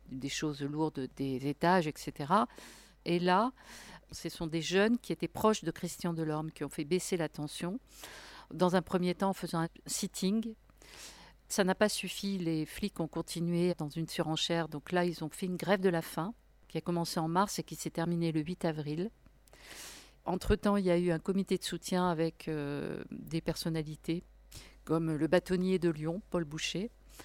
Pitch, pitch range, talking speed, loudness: 170 Hz, 160-185 Hz, 185 wpm, -34 LUFS